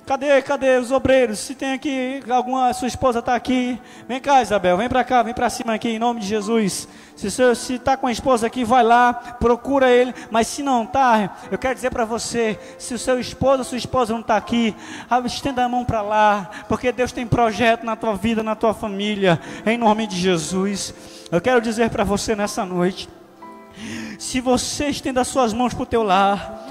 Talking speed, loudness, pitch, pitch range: 205 wpm, -20 LUFS, 240 Hz, 220-255 Hz